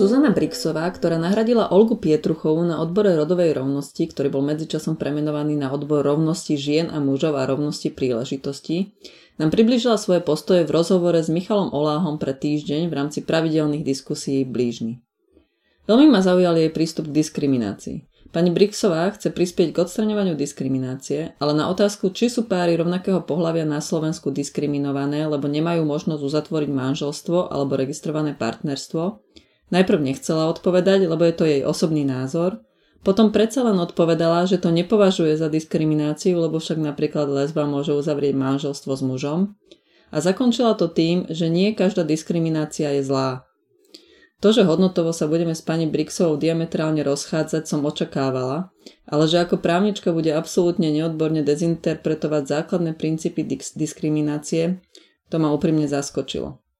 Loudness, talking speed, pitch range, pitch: -21 LUFS, 145 wpm, 150-180 Hz, 160 Hz